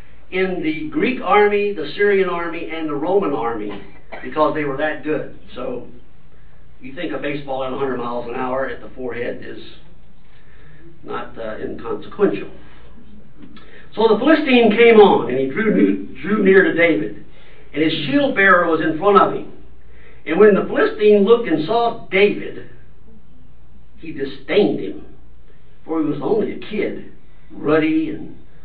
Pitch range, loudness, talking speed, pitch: 145-215 Hz, -17 LUFS, 155 wpm, 160 Hz